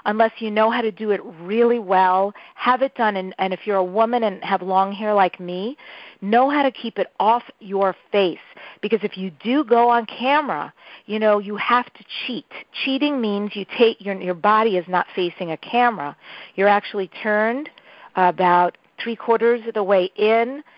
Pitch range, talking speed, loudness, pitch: 190-235 Hz, 195 wpm, -20 LUFS, 215 Hz